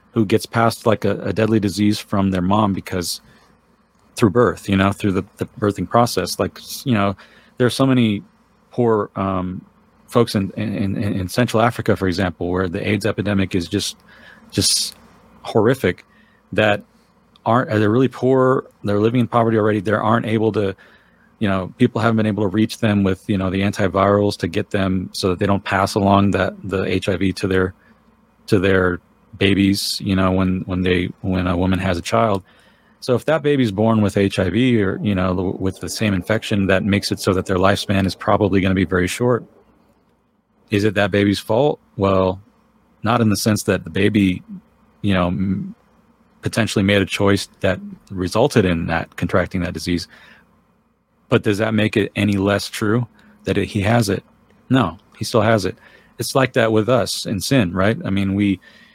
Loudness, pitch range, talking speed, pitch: -19 LUFS, 95-110 Hz, 190 wpm, 100 Hz